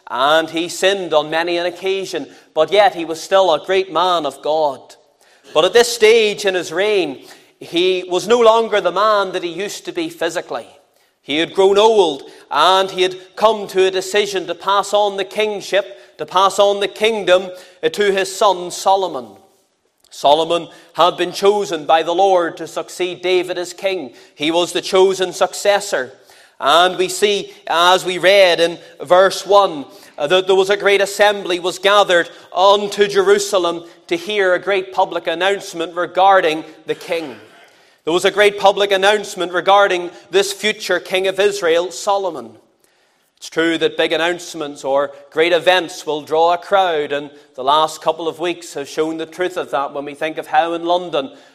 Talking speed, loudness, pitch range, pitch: 175 wpm, -16 LUFS, 165-200 Hz, 185 Hz